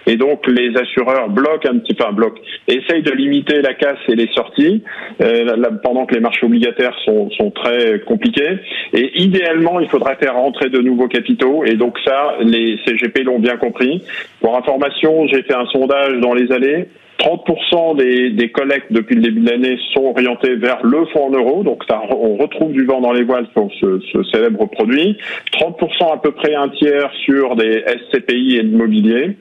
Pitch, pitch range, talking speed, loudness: 130 Hz, 120-160 Hz, 200 wpm, -14 LUFS